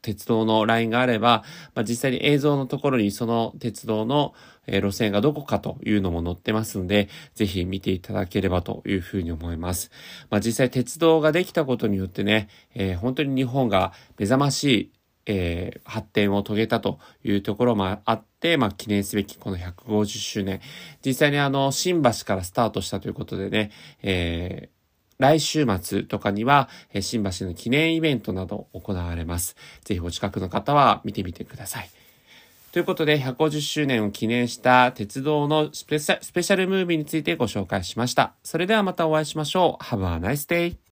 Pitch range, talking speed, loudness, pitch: 100-145 Hz, 365 characters per minute, -24 LUFS, 115 Hz